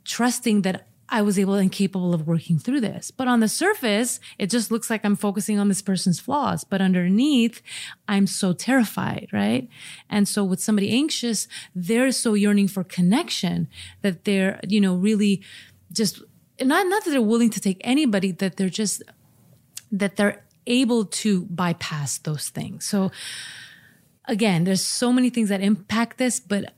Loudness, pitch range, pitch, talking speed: -22 LUFS, 190-235 Hz, 205 Hz, 170 wpm